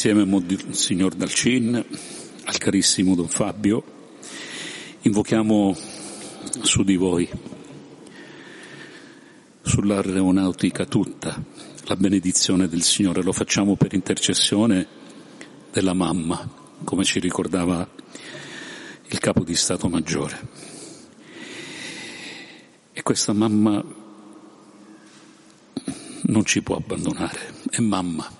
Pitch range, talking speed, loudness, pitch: 90-105 Hz, 85 wpm, -21 LUFS, 95 Hz